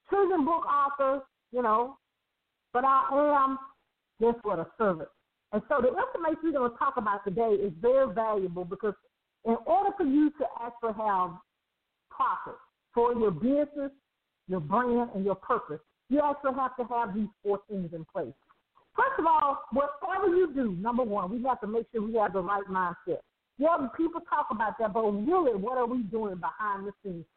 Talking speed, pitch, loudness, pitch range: 185 wpm, 245 Hz, -29 LUFS, 210-285 Hz